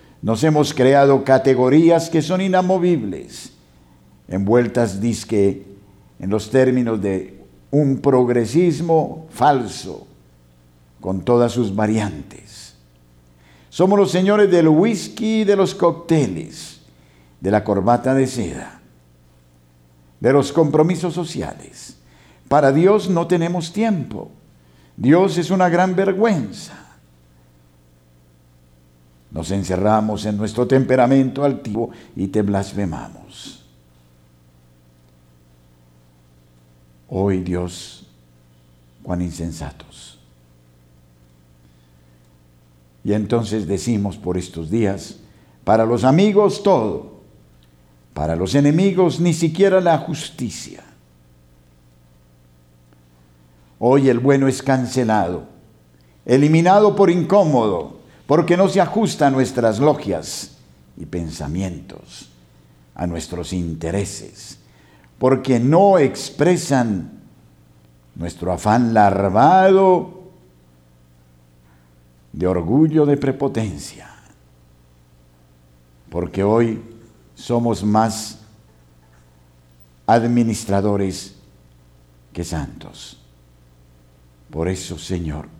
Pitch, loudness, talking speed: 95 Hz, -18 LUFS, 80 wpm